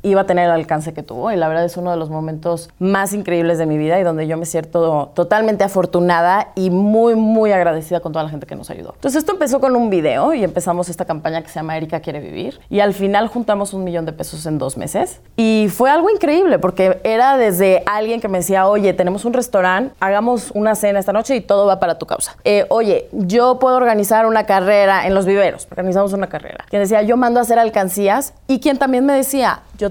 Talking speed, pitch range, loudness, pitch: 235 wpm, 175-225 Hz, -16 LUFS, 195 Hz